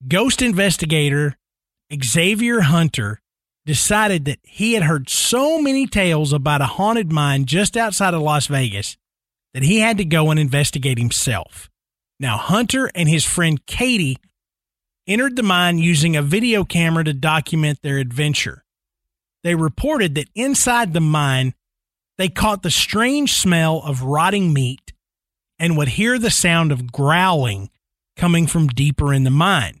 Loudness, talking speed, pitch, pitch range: -17 LUFS, 145 wpm, 160 Hz, 140-195 Hz